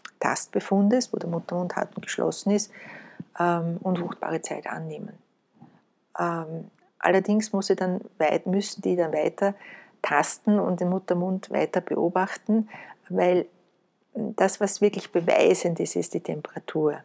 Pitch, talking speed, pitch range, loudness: 190 Hz, 130 wpm, 175-205 Hz, -26 LUFS